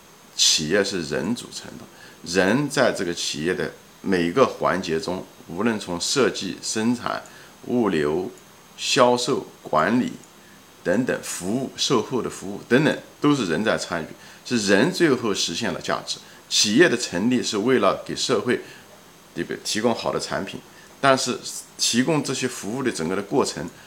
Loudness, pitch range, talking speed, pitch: -22 LUFS, 90-140 Hz, 230 characters per minute, 125 Hz